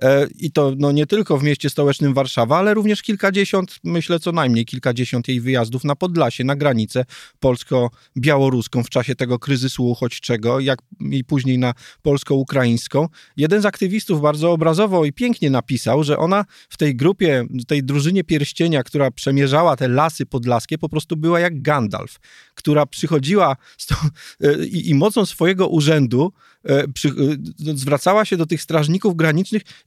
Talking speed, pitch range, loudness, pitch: 155 wpm, 130-170 Hz, -18 LUFS, 145 Hz